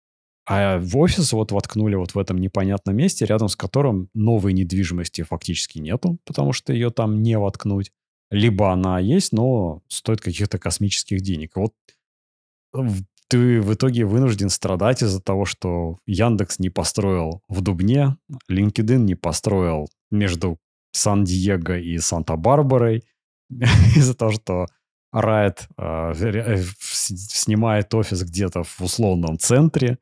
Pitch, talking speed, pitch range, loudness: 100 Hz, 125 wpm, 90-115 Hz, -20 LUFS